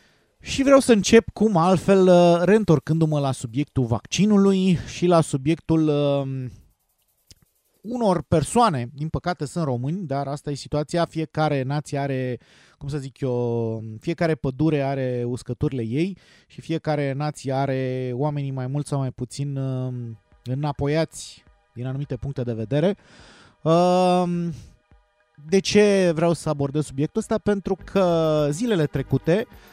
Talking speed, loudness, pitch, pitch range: 135 wpm, -22 LUFS, 150 Hz, 130-170 Hz